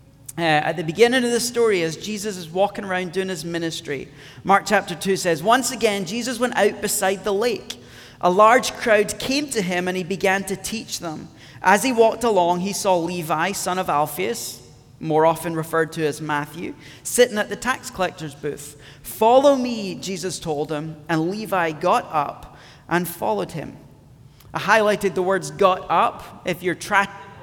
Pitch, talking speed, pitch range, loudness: 185 Hz, 180 wpm, 160-210 Hz, -21 LUFS